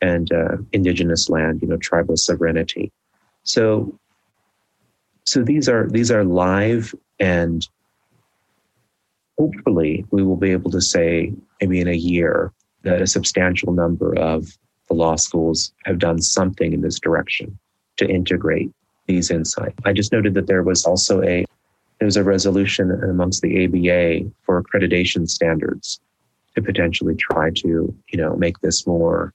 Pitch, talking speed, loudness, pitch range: 90 Hz, 145 wpm, -19 LUFS, 85-95 Hz